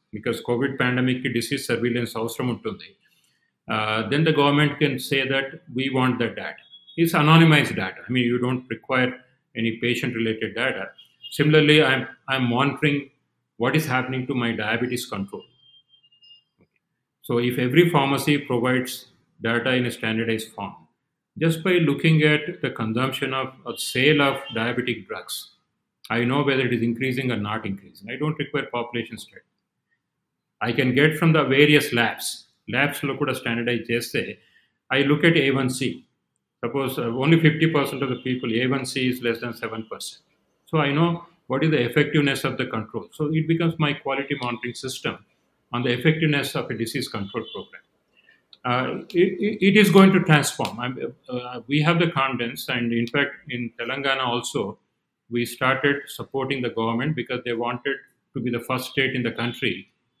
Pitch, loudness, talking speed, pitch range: 130 Hz, -22 LUFS, 165 wpm, 120-145 Hz